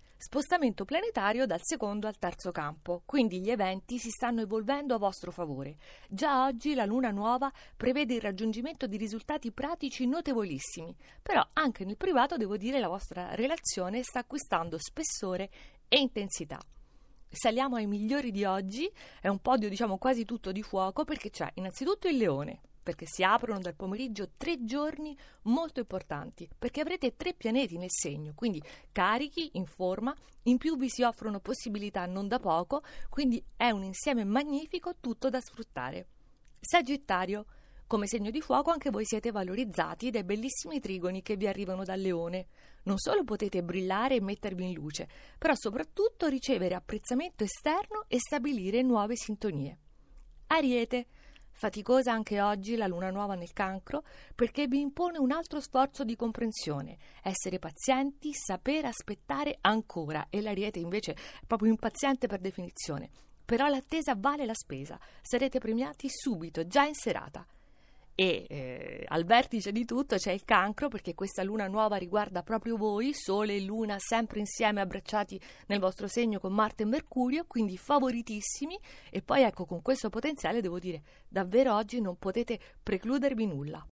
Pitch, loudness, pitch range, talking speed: 225 Hz, -32 LUFS, 195-265 Hz, 155 wpm